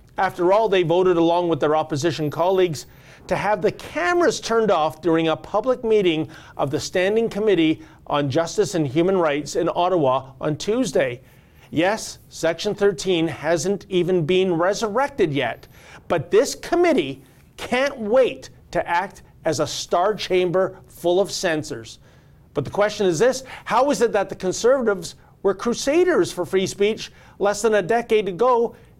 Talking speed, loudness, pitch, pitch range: 155 wpm, -21 LUFS, 185 Hz, 155-215 Hz